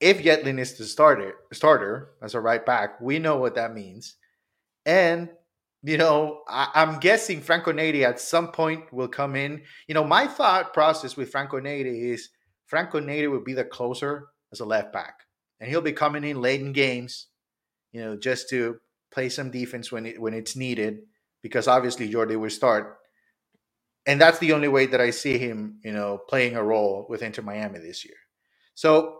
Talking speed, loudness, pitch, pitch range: 190 wpm, -24 LUFS, 135 Hz, 115-155 Hz